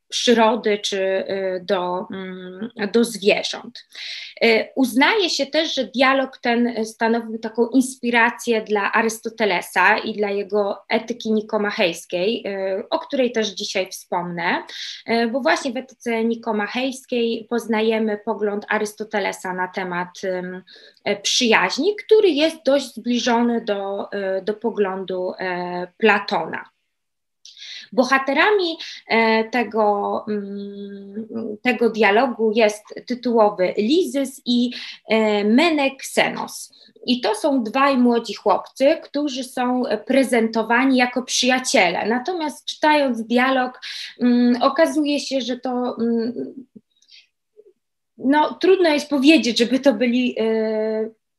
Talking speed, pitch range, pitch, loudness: 90 wpm, 210-265 Hz, 230 Hz, -20 LUFS